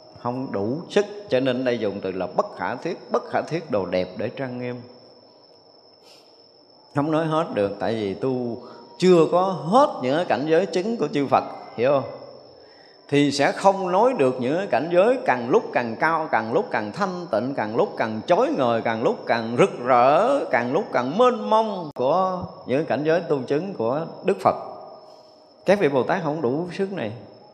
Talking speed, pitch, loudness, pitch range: 190 wpm, 150 Hz, -22 LUFS, 125-195 Hz